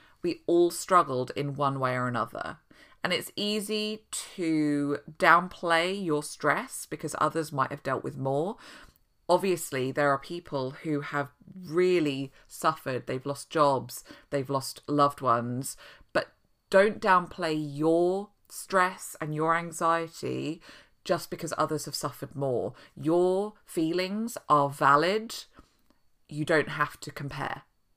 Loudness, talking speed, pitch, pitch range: -28 LUFS, 130 wpm, 155 Hz, 140-175 Hz